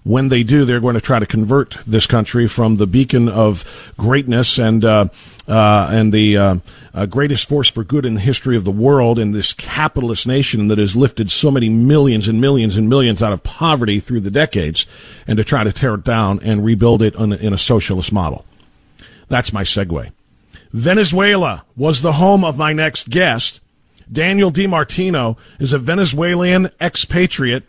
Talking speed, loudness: 185 wpm, -14 LUFS